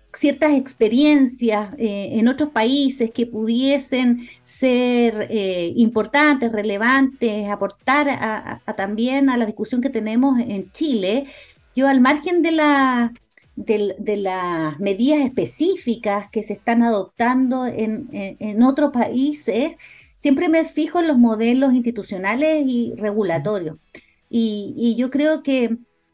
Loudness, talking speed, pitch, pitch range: -19 LUFS, 130 wpm, 240 Hz, 215-275 Hz